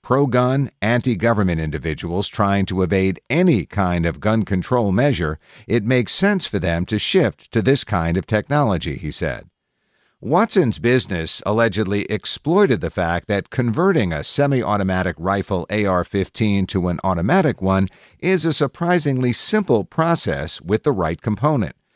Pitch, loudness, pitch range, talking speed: 105 Hz, -19 LUFS, 95-135 Hz, 150 wpm